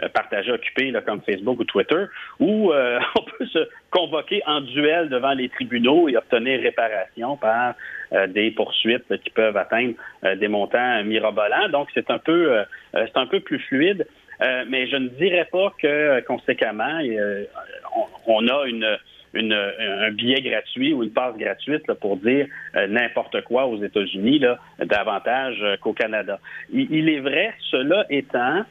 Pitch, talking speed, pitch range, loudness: 145 Hz, 170 wpm, 120-180 Hz, -21 LUFS